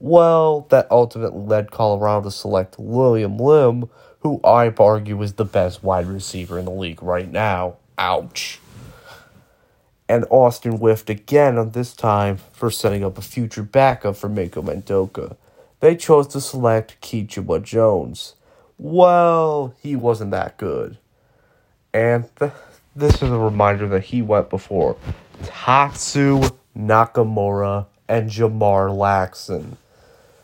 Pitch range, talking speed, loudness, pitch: 100-125 Hz, 130 wpm, -18 LUFS, 110 Hz